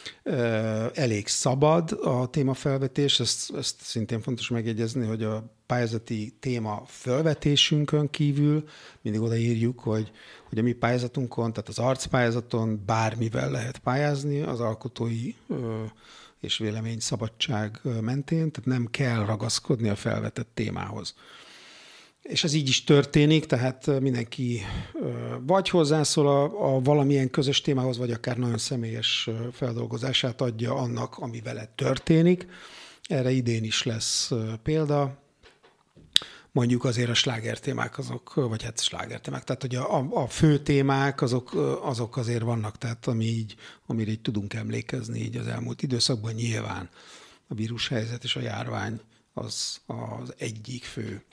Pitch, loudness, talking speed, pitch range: 120 Hz, -27 LUFS, 130 wpm, 115-135 Hz